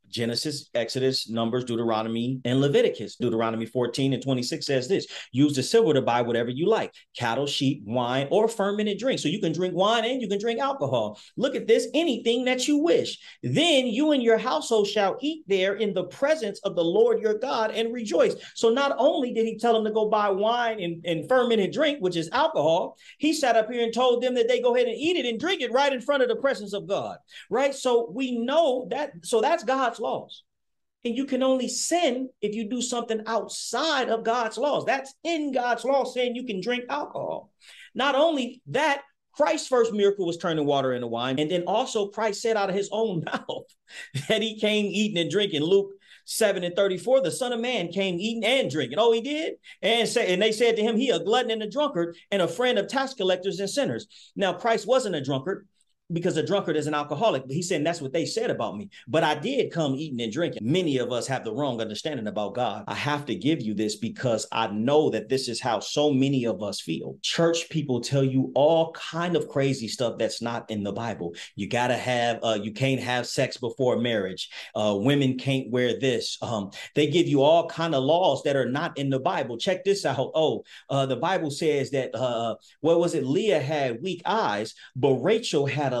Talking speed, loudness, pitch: 220 wpm, -25 LUFS, 195 Hz